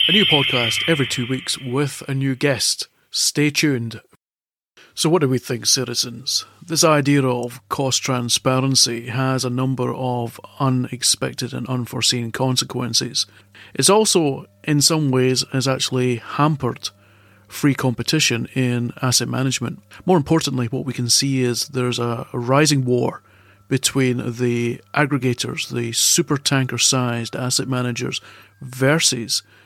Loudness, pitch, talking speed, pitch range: -19 LUFS, 130 Hz, 130 wpm, 120-140 Hz